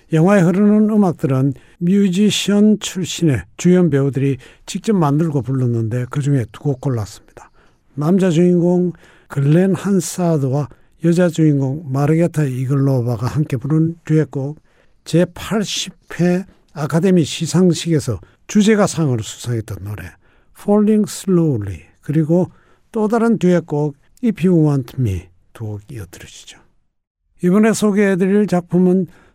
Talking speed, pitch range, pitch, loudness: 290 characters per minute, 135-185 Hz, 160 Hz, -16 LUFS